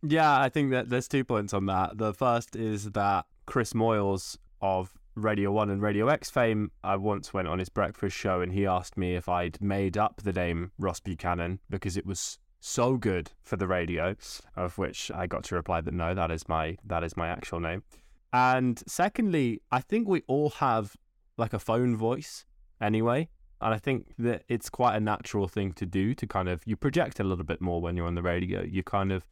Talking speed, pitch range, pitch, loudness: 215 wpm, 90-120 Hz, 100 Hz, -29 LUFS